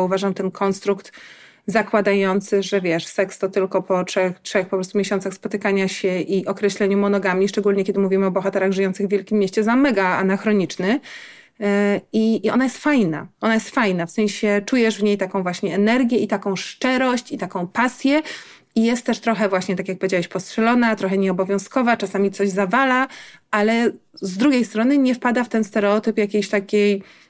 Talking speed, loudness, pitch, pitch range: 175 wpm, -20 LUFS, 200 Hz, 195-225 Hz